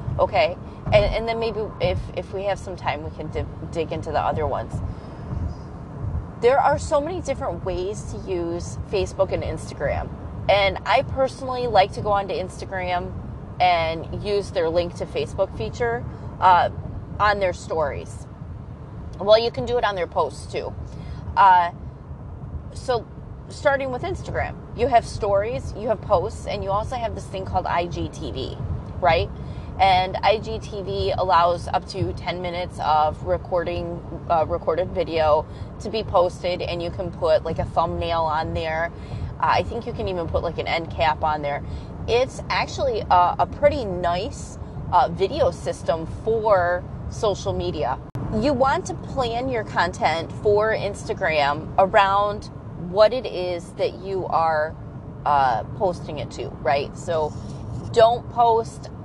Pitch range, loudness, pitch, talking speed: 170-230 Hz, -23 LUFS, 190 Hz, 150 wpm